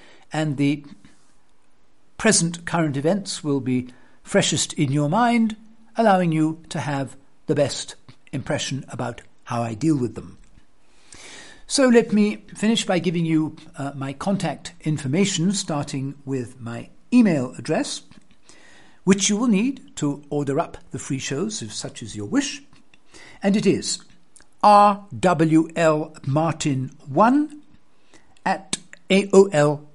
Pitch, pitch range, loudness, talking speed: 155 Hz, 140-200 Hz, -22 LUFS, 120 wpm